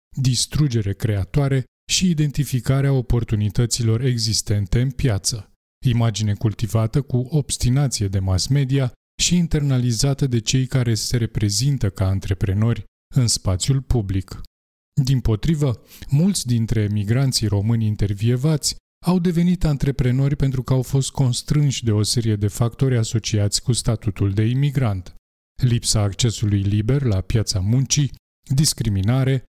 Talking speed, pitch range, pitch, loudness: 120 wpm, 105-135 Hz, 120 Hz, -20 LUFS